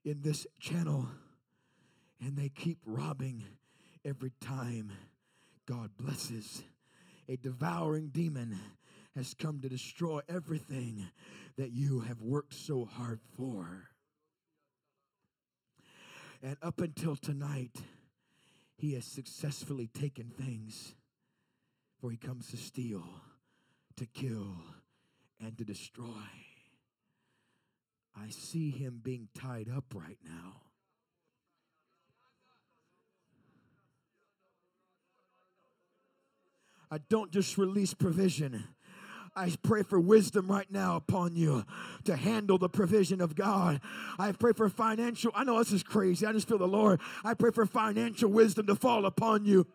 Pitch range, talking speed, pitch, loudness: 125-190 Hz, 115 wpm, 145 Hz, -33 LUFS